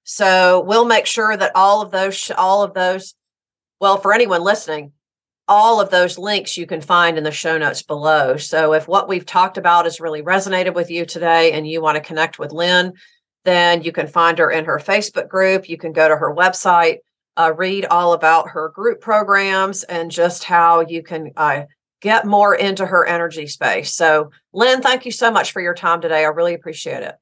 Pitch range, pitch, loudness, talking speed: 160-195 Hz, 175 Hz, -16 LUFS, 205 wpm